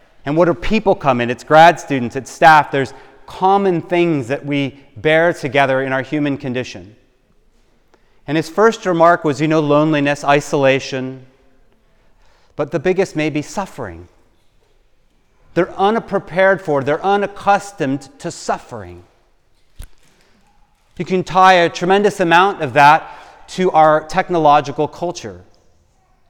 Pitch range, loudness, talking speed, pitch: 135-175 Hz, -15 LUFS, 130 wpm, 150 Hz